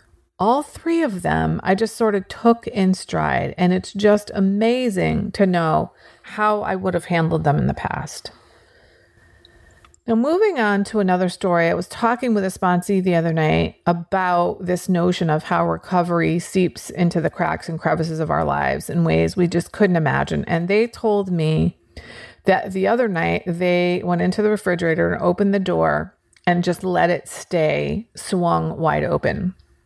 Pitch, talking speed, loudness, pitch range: 180 Hz, 175 wpm, -20 LUFS, 160-200 Hz